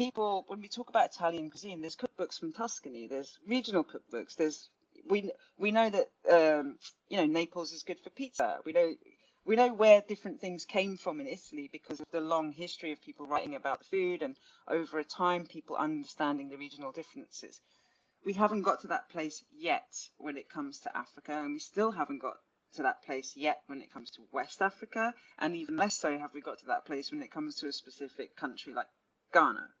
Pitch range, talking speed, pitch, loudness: 155-235 Hz, 205 wpm, 175 Hz, -34 LUFS